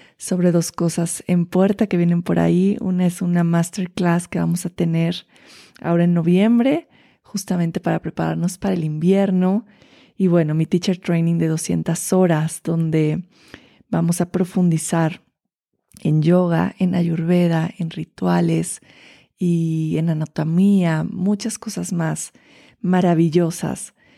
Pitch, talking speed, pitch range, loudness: 175 Hz, 125 wpm, 165-185 Hz, -19 LUFS